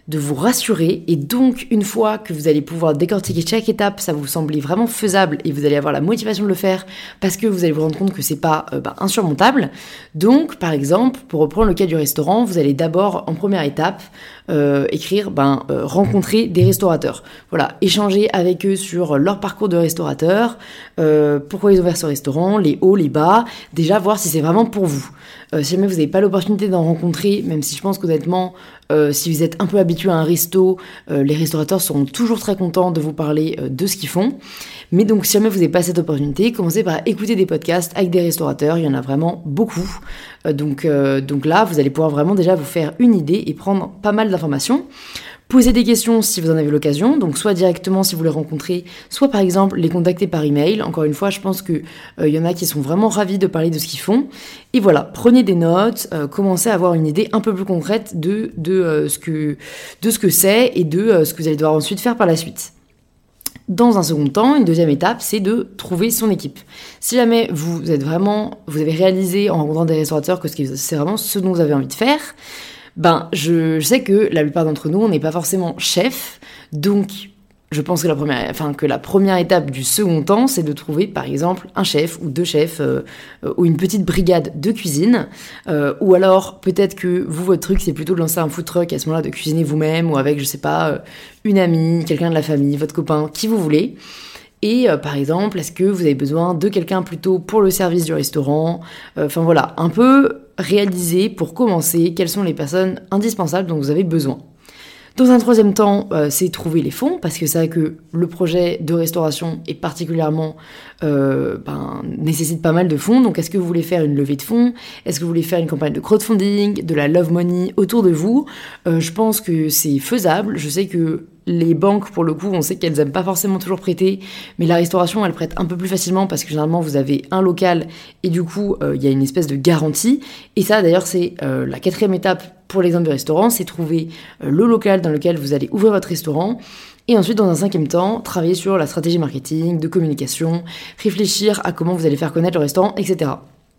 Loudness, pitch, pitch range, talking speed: -17 LUFS, 175 Hz, 155-200 Hz, 230 wpm